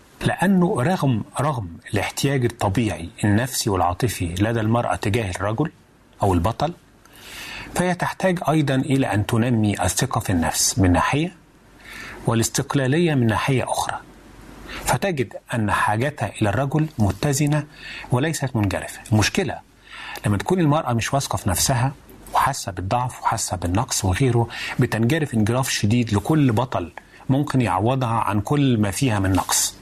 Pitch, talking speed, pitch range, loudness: 120 Hz, 125 wpm, 105-140 Hz, -21 LUFS